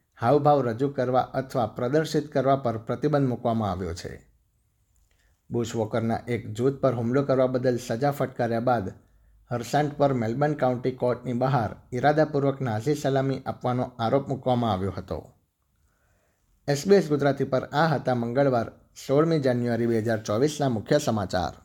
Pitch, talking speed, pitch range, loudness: 125 Hz, 135 wpm, 115-140 Hz, -25 LUFS